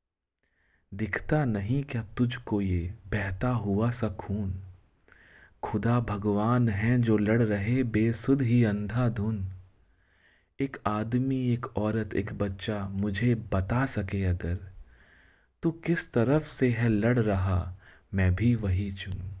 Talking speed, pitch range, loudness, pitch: 120 wpm, 95-120 Hz, -28 LUFS, 105 Hz